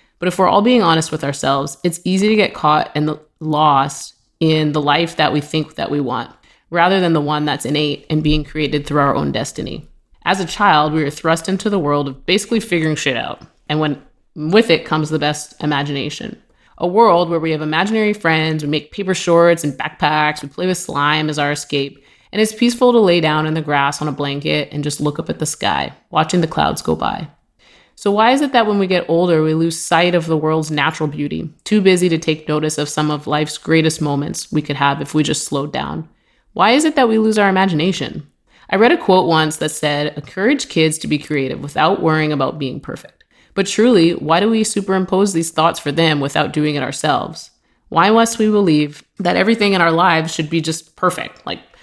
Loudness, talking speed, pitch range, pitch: -16 LUFS, 220 wpm, 150-185 Hz, 155 Hz